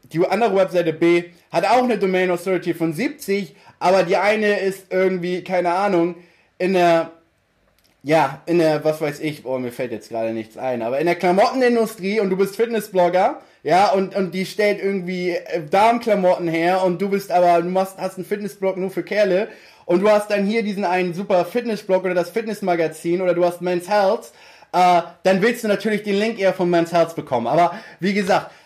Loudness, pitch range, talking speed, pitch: -19 LUFS, 170-200 Hz, 195 wpm, 185 Hz